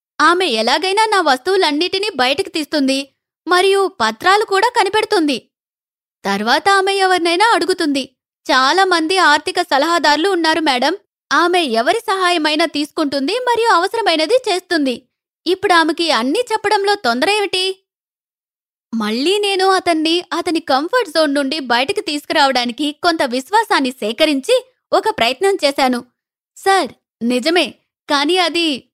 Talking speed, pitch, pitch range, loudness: 105 wpm, 335 Hz, 285-385 Hz, -15 LUFS